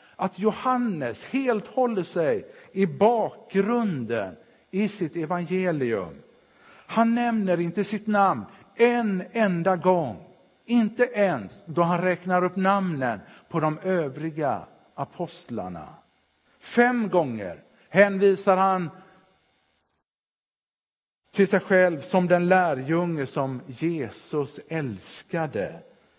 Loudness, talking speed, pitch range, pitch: -25 LUFS, 95 wpm, 160-205 Hz, 185 Hz